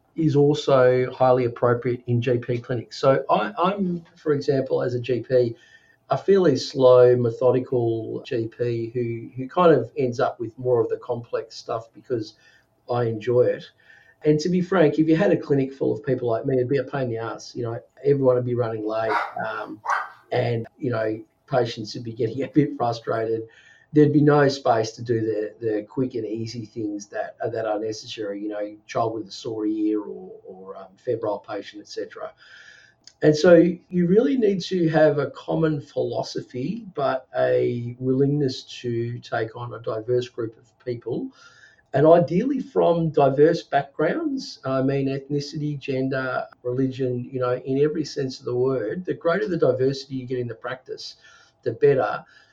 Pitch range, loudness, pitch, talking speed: 120-150 Hz, -23 LUFS, 130 Hz, 180 wpm